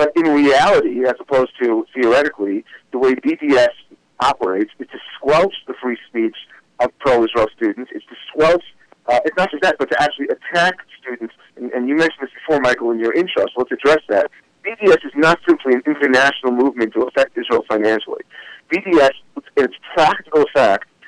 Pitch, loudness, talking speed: 155 Hz, -16 LUFS, 180 wpm